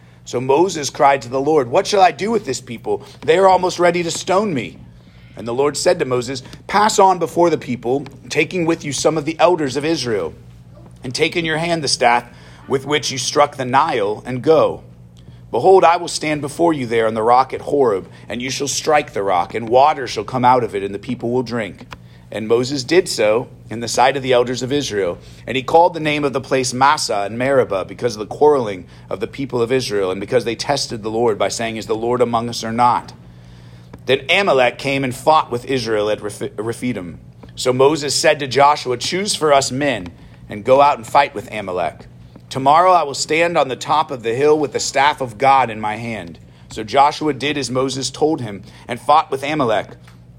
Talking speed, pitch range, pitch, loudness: 220 wpm, 115-150 Hz, 130 Hz, -17 LUFS